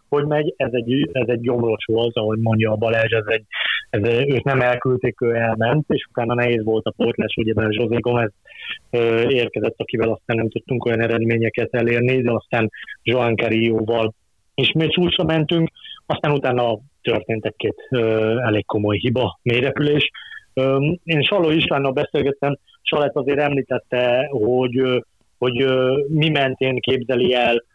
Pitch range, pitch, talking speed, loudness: 115-135 Hz, 125 Hz, 150 wpm, -19 LUFS